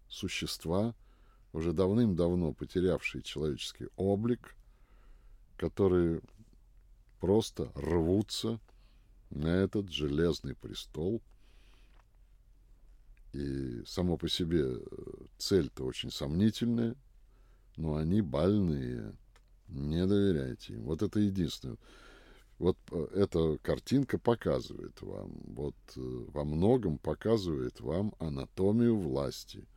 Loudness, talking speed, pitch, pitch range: -33 LUFS, 85 wpm, 95 Hz, 80-110 Hz